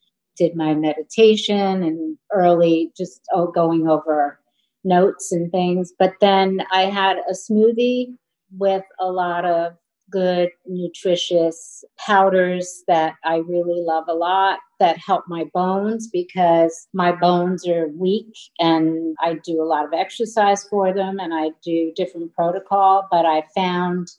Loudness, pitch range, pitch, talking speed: -19 LUFS, 165-195 Hz, 180 Hz, 140 wpm